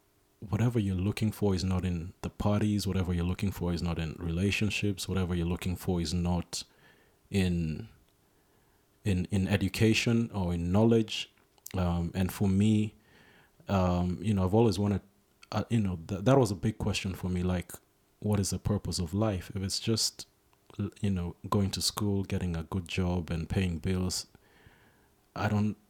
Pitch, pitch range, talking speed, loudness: 95 Hz, 90-105 Hz, 175 wpm, -31 LUFS